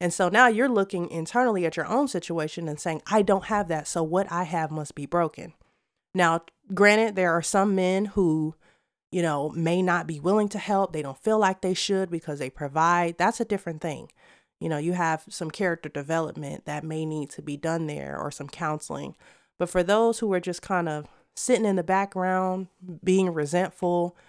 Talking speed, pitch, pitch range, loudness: 205 wpm, 175 Hz, 160-195 Hz, -26 LUFS